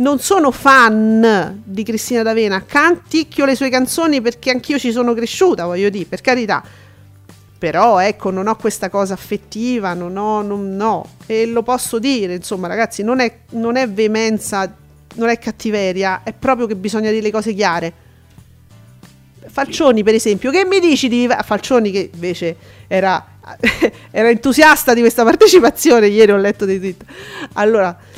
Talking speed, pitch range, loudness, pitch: 160 wpm, 190-245 Hz, -14 LUFS, 220 Hz